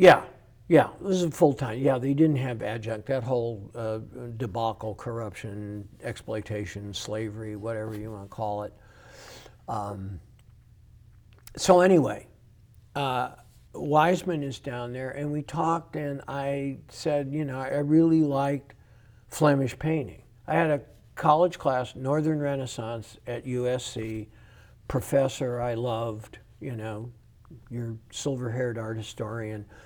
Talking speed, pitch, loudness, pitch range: 125 wpm, 120 Hz, -28 LUFS, 110-140 Hz